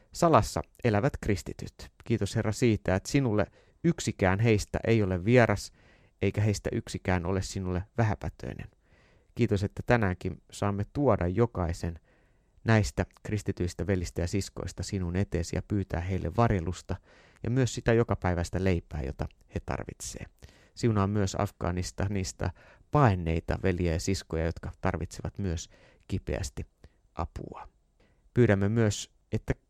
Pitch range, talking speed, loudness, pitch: 90-105 Hz, 125 wpm, -30 LUFS, 95 Hz